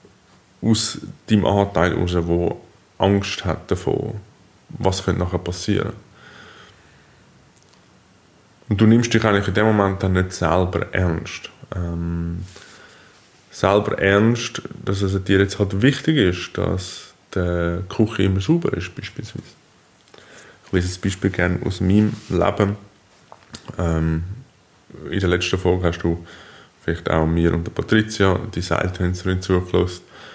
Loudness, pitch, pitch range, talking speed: -20 LUFS, 95 Hz, 90-105 Hz, 130 wpm